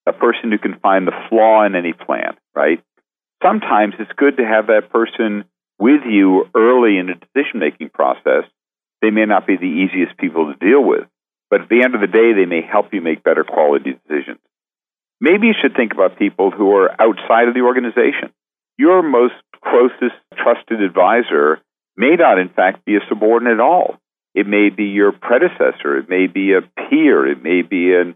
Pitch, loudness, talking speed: 110 Hz, -14 LUFS, 190 wpm